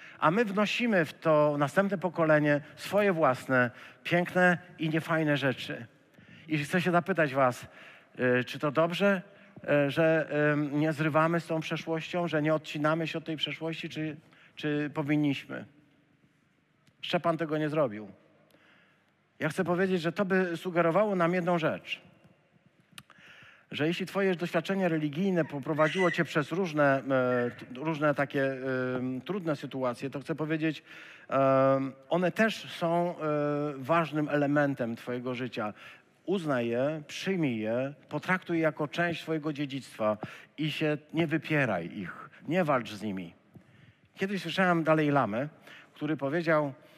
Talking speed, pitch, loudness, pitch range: 125 wpm, 155 Hz, -29 LUFS, 145-170 Hz